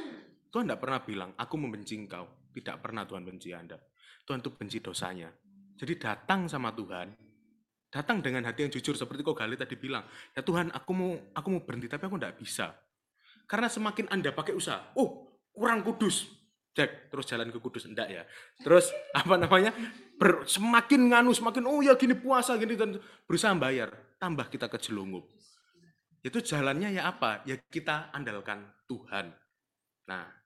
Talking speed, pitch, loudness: 165 wpm, 150 Hz, -30 LUFS